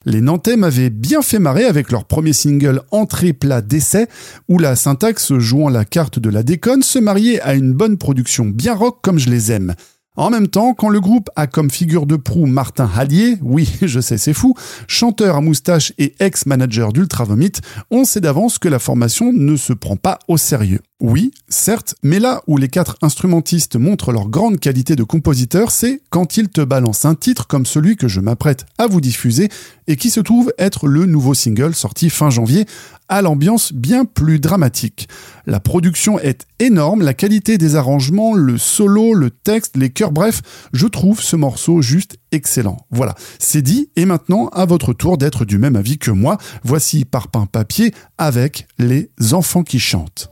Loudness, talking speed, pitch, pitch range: -14 LUFS, 190 wpm, 155 Hz, 125-195 Hz